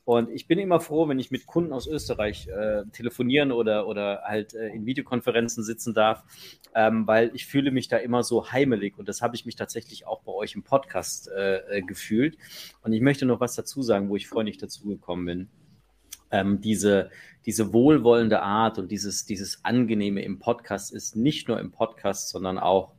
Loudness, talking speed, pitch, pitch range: -26 LUFS, 190 wpm, 110 Hz, 100-120 Hz